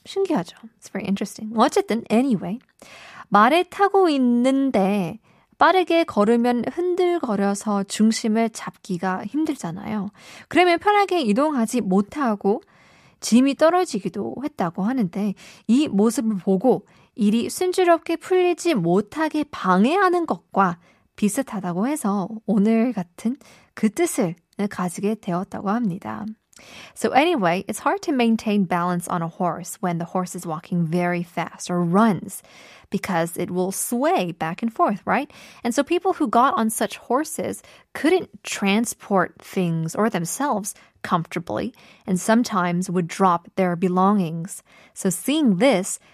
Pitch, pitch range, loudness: 215 Hz, 185-265 Hz, -22 LUFS